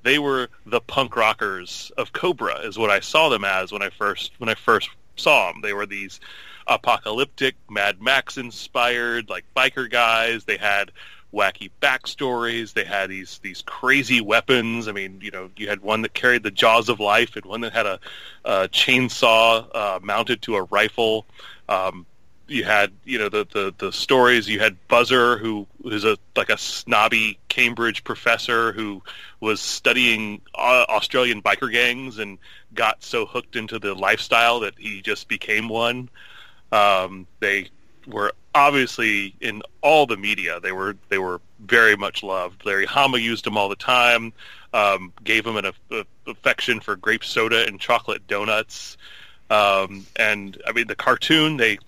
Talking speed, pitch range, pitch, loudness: 170 wpm, 100-120 Hz, 115 Hz, -20 LUFS